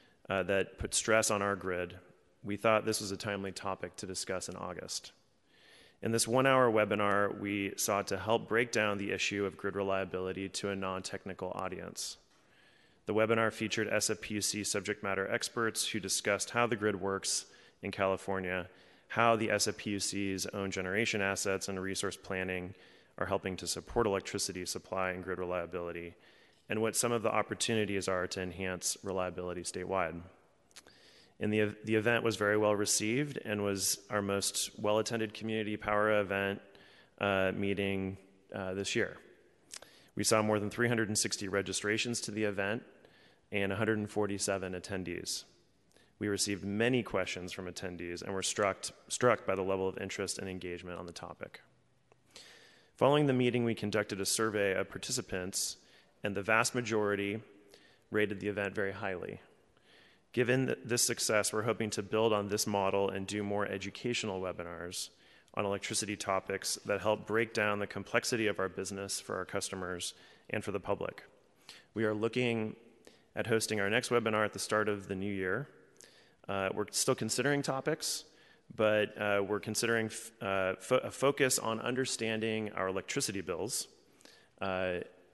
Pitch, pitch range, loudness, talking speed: 100 Hz, 95-110 Hz, -34 LUFS, 155 wpm